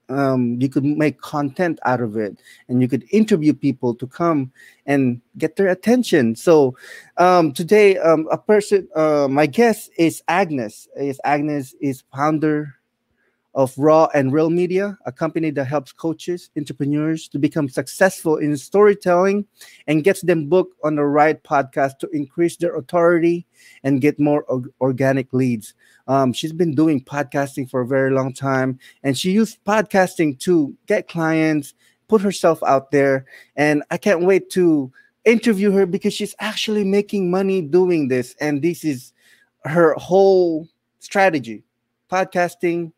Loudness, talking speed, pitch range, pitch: -19 LUFS, 155 wpm, 140-180 Hz, 155 Hz